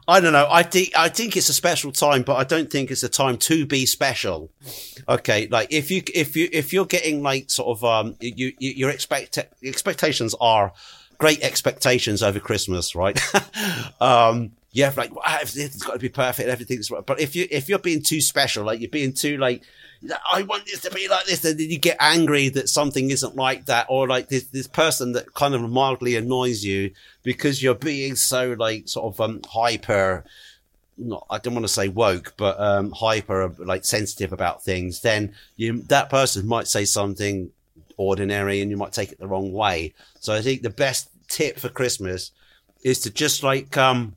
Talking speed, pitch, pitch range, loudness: 200 wpm, 125 Hz, 110-145 Hz, -21 LUFS